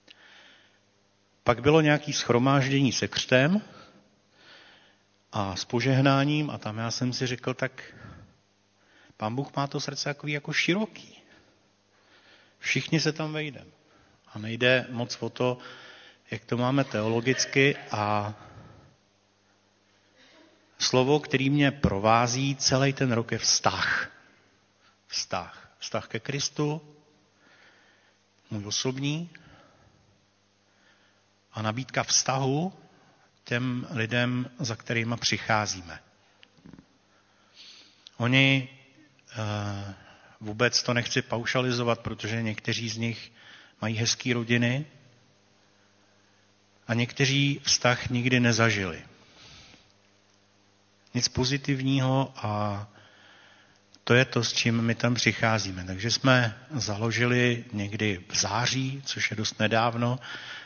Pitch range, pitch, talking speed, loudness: 100-130 Hz, 115 Hz, 100 wpm, -26 LUFS